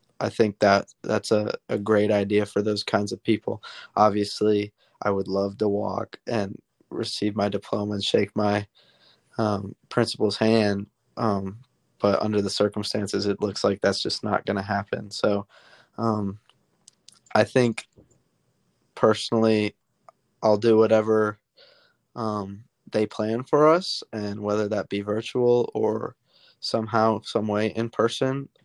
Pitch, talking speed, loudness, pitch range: 105 Hz, 140 wpm, -24 LUFS, 100-110 Hz